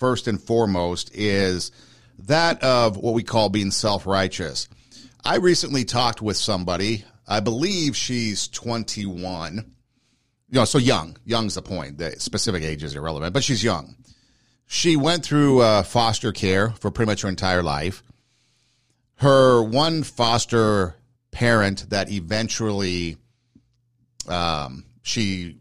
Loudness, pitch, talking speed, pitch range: -22 LUFS, 115 Hz, 130 wpm, 95-125 Hz